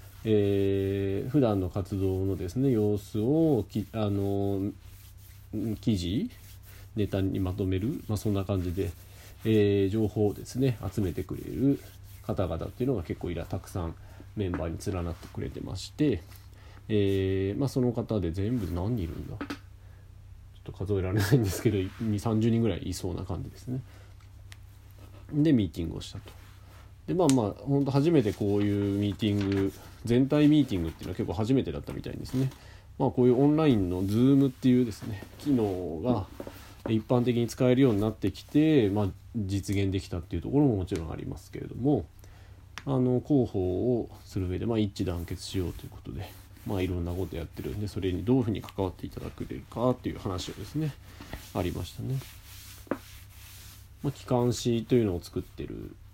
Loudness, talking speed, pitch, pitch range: -29 LUFS, 355 characters per minute, 100 Hz, 95-120 Hz